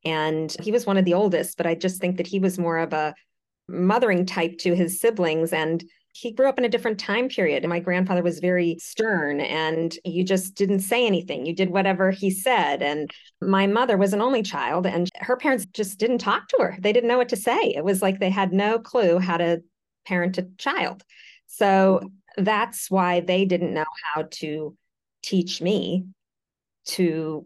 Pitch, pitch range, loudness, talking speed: 185 Hz, 170-200 Hz, -23 LUFS, 200 wpm